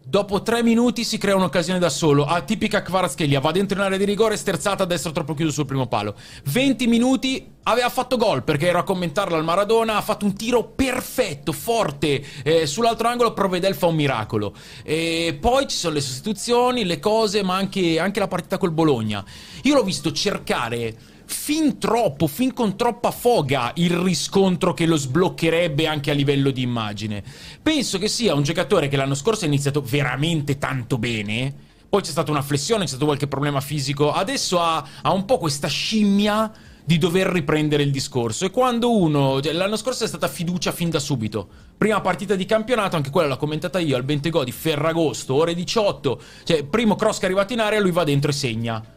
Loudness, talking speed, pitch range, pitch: -21 LUFS, 190 wpm, 145-210 Hz, 175 Hz